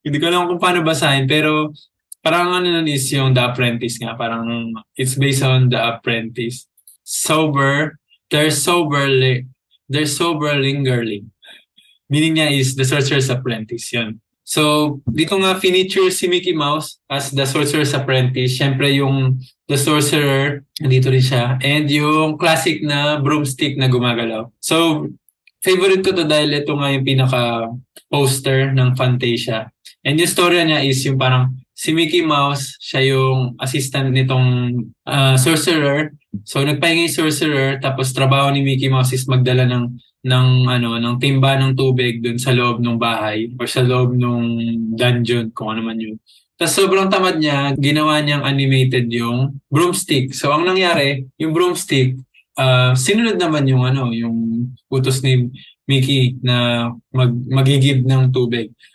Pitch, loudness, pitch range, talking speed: 135 Hz, -16 LUFS, 125-150 Hz, 150 wpm